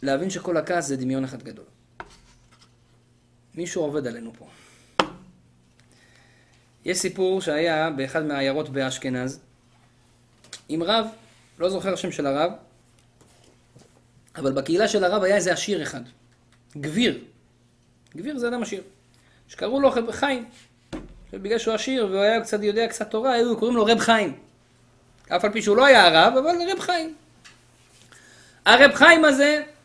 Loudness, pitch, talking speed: -21 LUFS, 180 Hz, 135 wpm